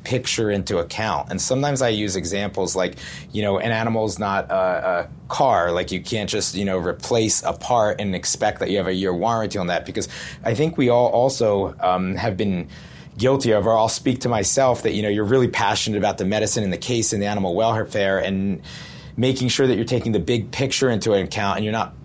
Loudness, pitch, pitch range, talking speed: -21 LUFS, 110 Hz, 100-120 Hz, 225 wpm